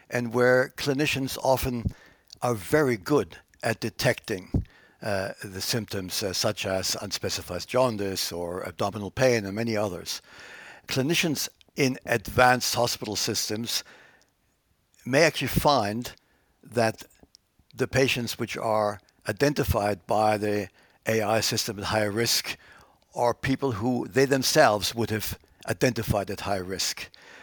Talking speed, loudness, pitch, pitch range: 120 wpm, -26 LUFS, 115 Hz, 100-125 Hz